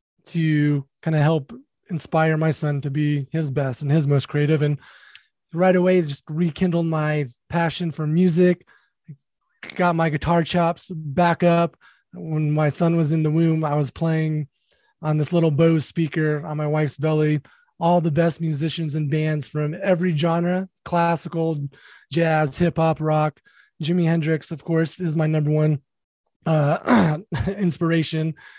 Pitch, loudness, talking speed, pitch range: 160 Hz, -21 LUFS, 155 wpm, 150-170 Hz